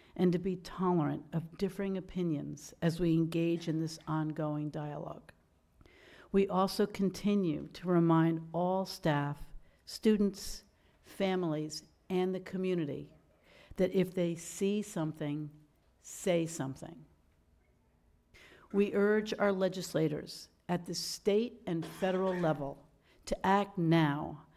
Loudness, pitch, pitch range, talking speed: -33 LUFS, 170 Hz, 155-190 Hz, 110 wpm